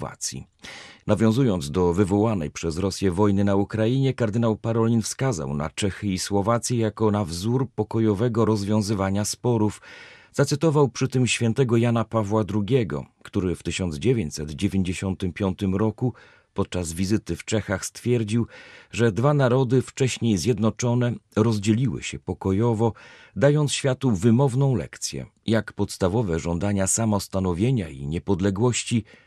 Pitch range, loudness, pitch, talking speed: 95-120 Hz, -24 LUFS, 110 Hz, 115 wpm